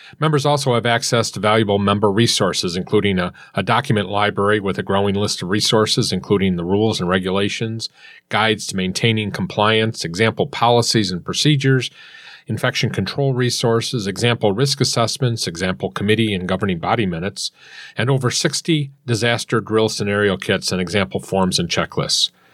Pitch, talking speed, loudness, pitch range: 110 Hz, 150 wpm, -18 LUFS, 100-120 Hz